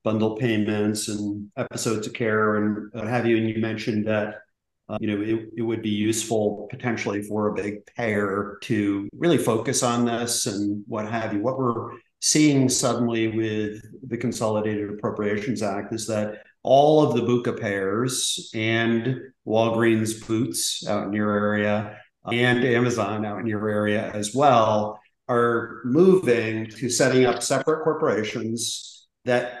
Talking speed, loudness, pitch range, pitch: 155 wpm, -23 LUFS, 105-120 Hz, 110 Hz